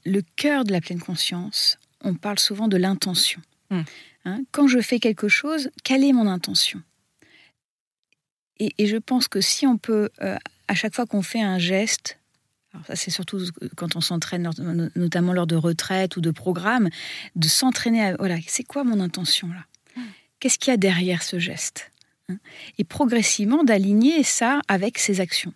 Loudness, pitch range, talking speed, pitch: -22 LUFS, 180-235 Hz, 175 wpm, 195 Hz